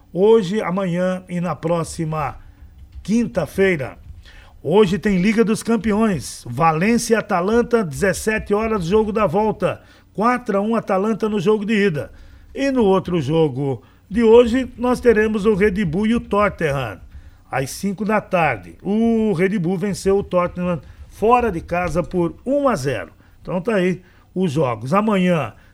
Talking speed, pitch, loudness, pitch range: 150 wpm, 190 Hz, -19 LUFS, 160-215 Hz